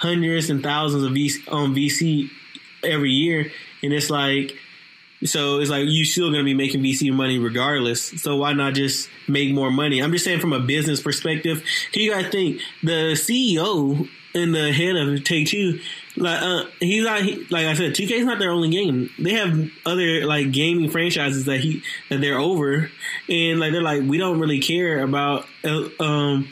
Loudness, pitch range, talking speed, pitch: -21 LUFS, 140-170 Hz, 190 wpm, 150 Hz